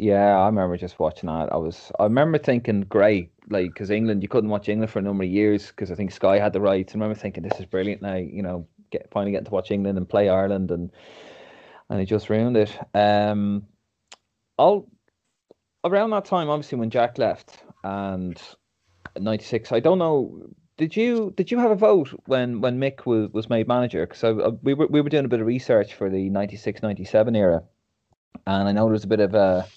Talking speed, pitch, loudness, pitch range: 220 wpm, 105 Hz, -23 LUFS, 100-120 Hz